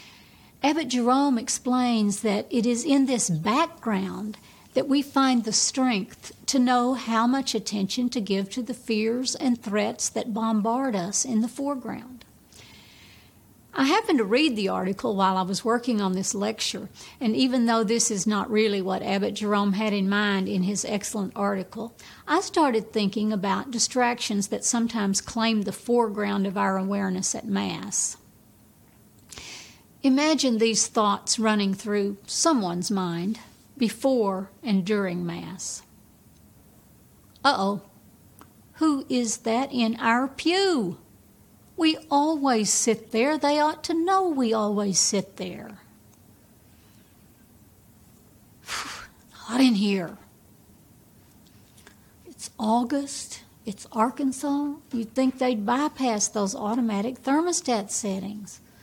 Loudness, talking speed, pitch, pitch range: -25 LUFS, 125 wpm, 225 Hz, 200-255 Hz